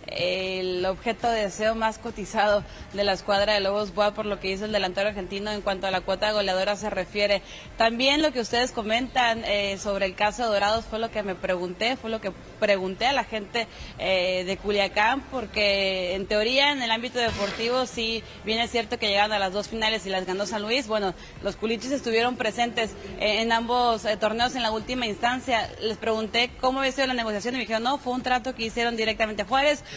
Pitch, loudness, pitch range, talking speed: 215 Hz, -25 LUFS, 200-235 Hz, 215 wpm